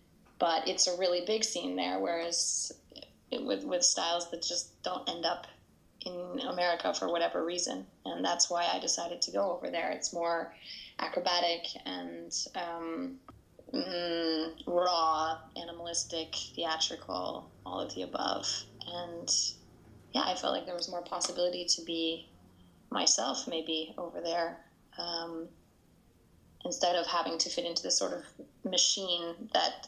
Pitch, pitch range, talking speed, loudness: 170 Hz, 165-180 Hz, 145 wpm, -32 LUFS